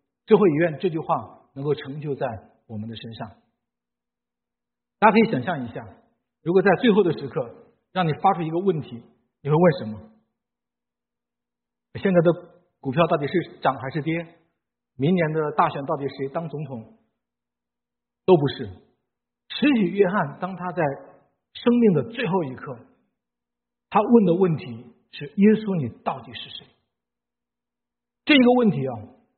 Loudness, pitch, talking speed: -22 LUFS, 140 Hz, 210 characters per minute